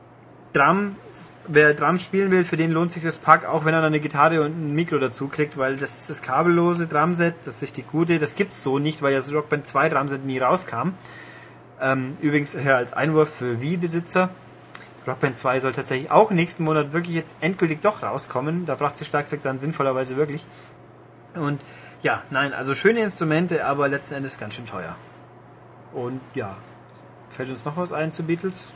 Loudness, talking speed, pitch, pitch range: -22 LUFS, 190 wpm, 150 Hz, 135-165 Hz